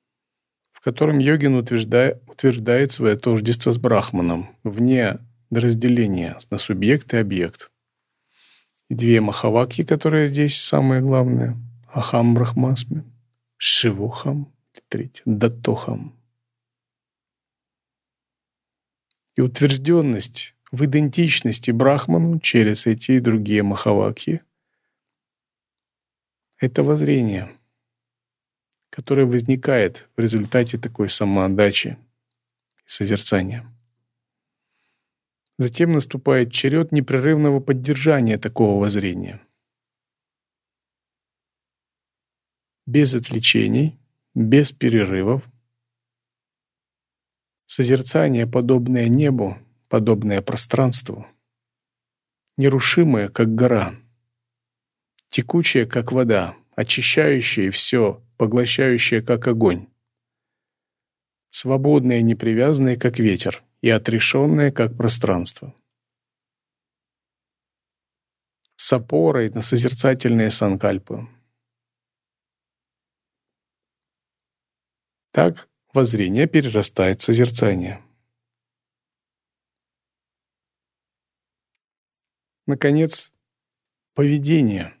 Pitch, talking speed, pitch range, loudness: 120 Hz, 65 wpm, 110-130 Hz, -18 LUFS